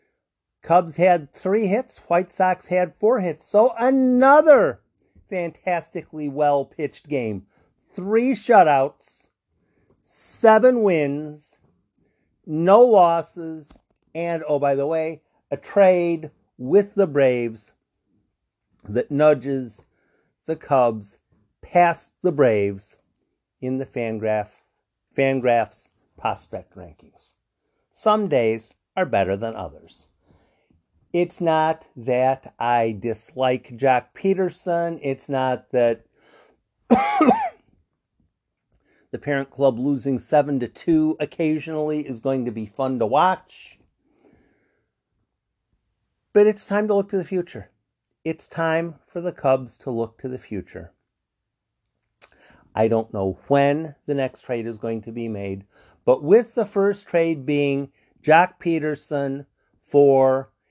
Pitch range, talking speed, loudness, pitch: 120-175 Hz, 115 wpm, -21 LUFS, 145 Hz